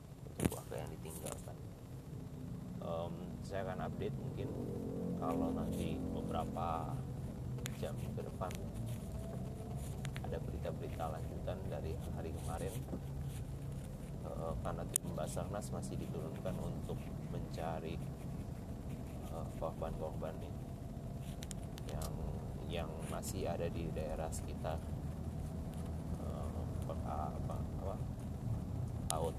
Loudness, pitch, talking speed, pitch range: -43 LUFS, 75 Hz, 80 wpm, 70-80 Hz